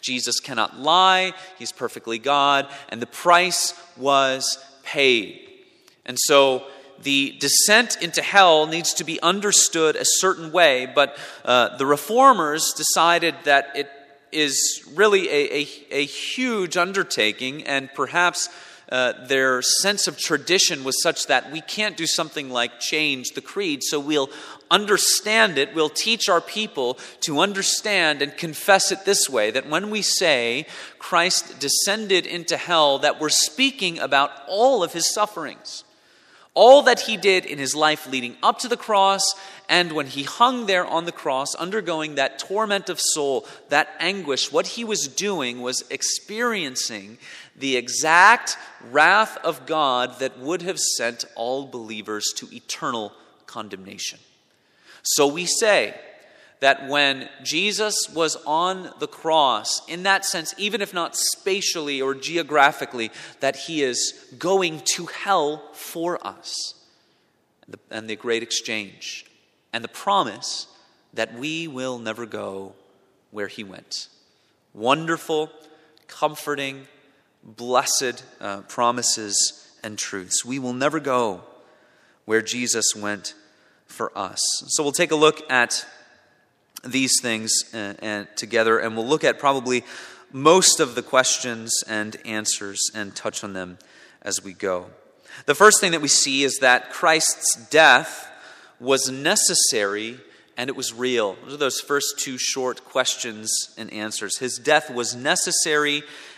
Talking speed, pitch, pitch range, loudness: 140 wpm, 145 Hz, 125-175 Hz, -20 LUFS